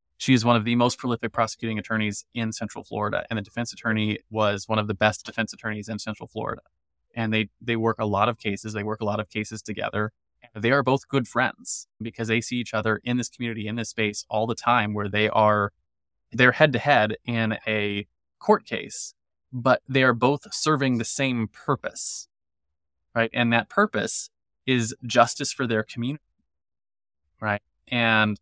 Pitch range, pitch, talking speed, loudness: 105-120 Hz, 110 Hz, 190 wpm, -25 LUFS